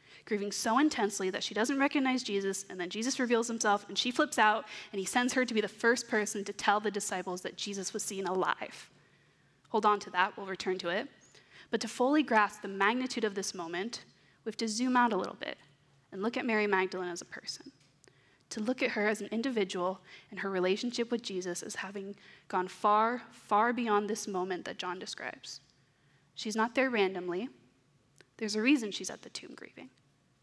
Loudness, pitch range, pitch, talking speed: -32 LUFS, 185-230 Hz, 205 Hz, 205 wpm